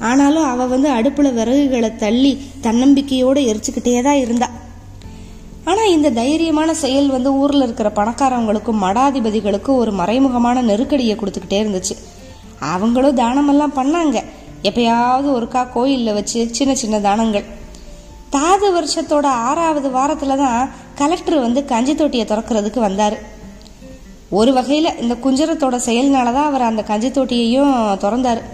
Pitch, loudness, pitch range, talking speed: 250 Hz, -16 LUFS, 215-275 Hz, 115 wpm